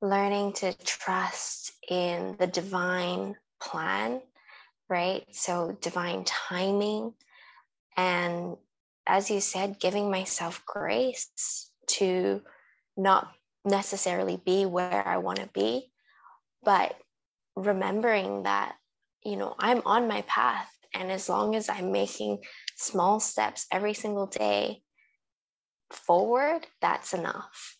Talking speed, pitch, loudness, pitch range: 110 wpm, 190 Hz, -29 LUFS, 180-205 Hz